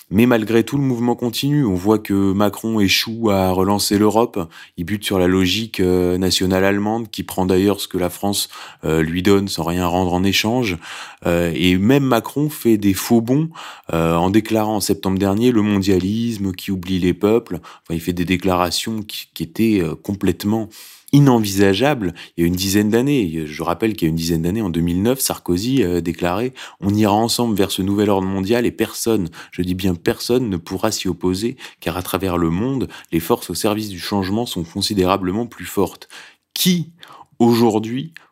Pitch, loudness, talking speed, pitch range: 100 Hz, -18 LUFS, 180 wpm, 90-115 Hz